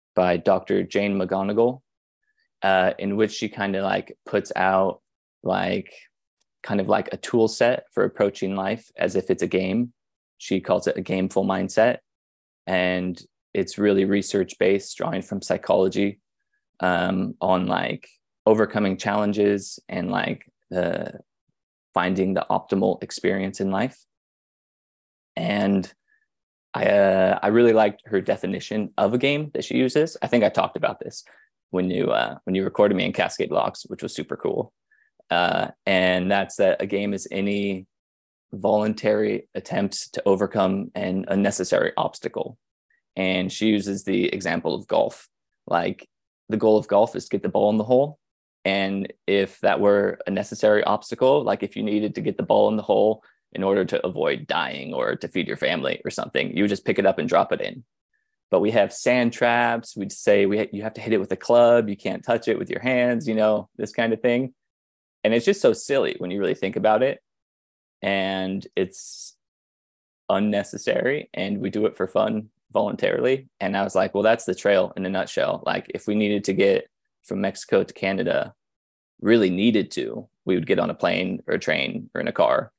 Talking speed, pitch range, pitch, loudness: 185 wpm, 95-115 Hz, 100 Hz, -23 LUFS